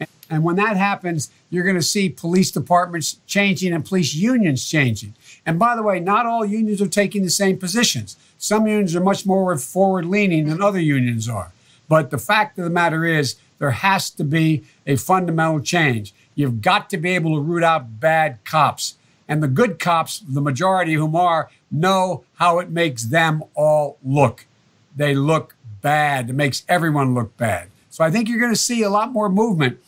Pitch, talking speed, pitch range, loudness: 165 Hz, 190 wpm, 145-190 Hz, -19 LUFS